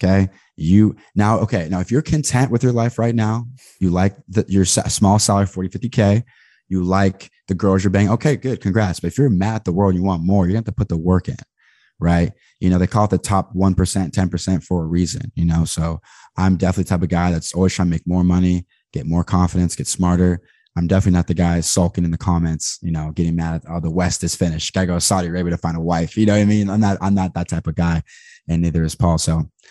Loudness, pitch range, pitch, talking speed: -18 LUFS, 85-100 Hz, 90 Hz, 265 wpm